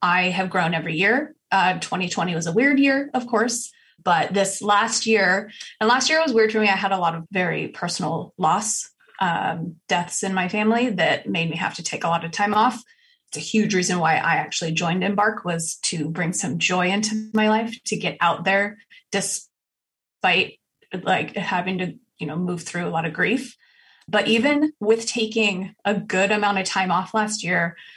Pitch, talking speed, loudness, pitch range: 195 Hz, 200 wpm, -21 LUFS, 170-220 Hz